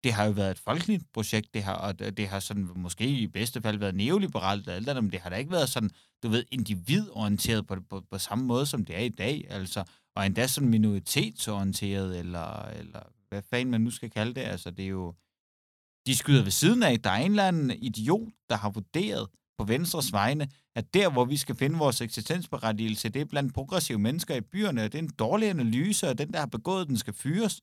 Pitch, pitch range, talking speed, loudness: 115 Hz, 100-140 Hz, 230 wpm, -29 LUFS